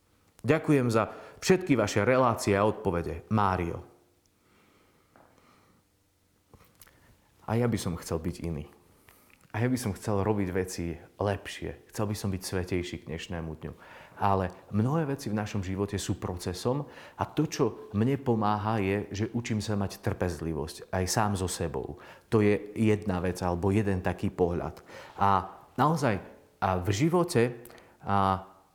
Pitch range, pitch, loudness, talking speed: 90-110 Hz, 100 Hz, -29 LUFS, 140 wpm